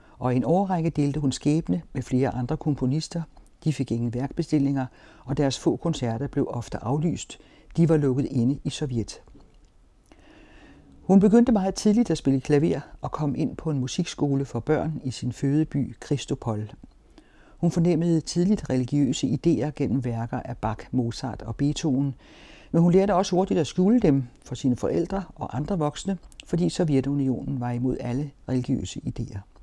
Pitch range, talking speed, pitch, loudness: 125-165 Hz, 160 wpm, 140 Hz, -25 LUFS